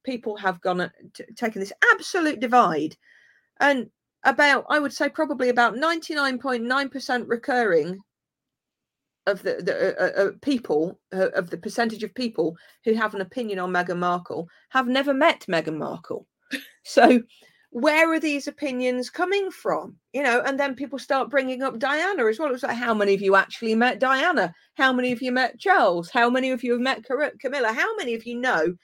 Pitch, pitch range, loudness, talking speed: 255 Hz, 215-285 Hz, -23 LUFS, 185 wpm